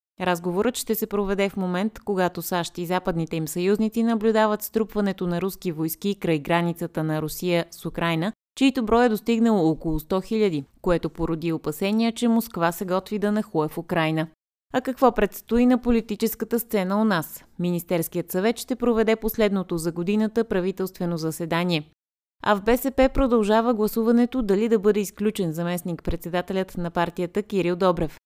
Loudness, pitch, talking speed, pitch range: -24 LUFS, 195 Hz, 155 wpm, 170-220 Hz